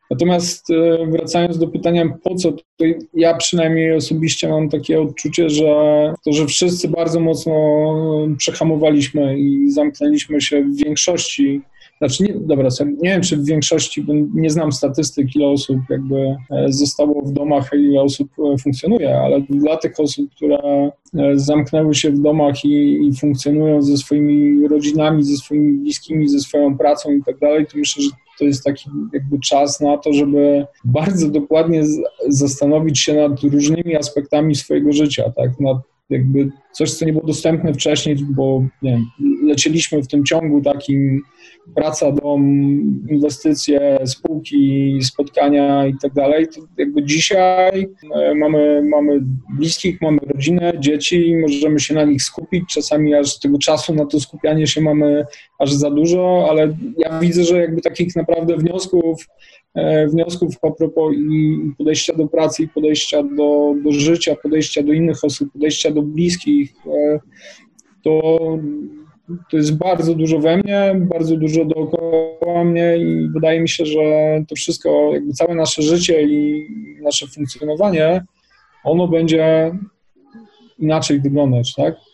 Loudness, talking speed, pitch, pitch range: -16 LUFS, 145 wpm, 150 Hz, 145-165 Hz